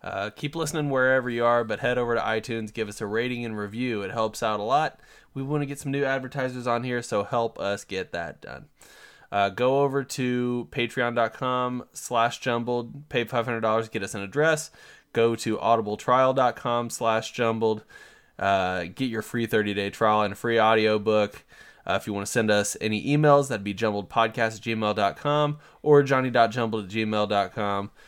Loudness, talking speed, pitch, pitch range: -25 LUFS, 170 wpm, 115 Hz, 110-125 Hz